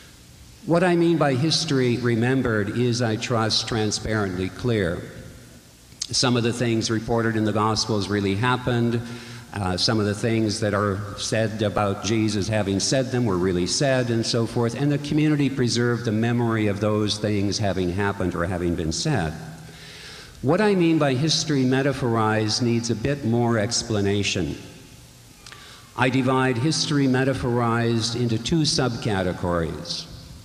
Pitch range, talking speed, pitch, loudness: 105-125 Hz, 145 wpm, 115 Hz, -22 LUFS